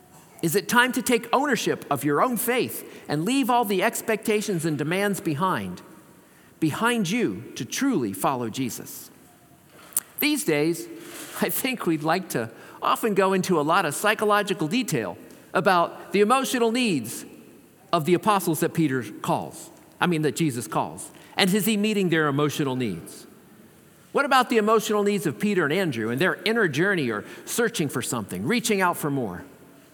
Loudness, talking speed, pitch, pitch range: -24 LUFS, 165 wpm, 195 Hz, 160-230 Hz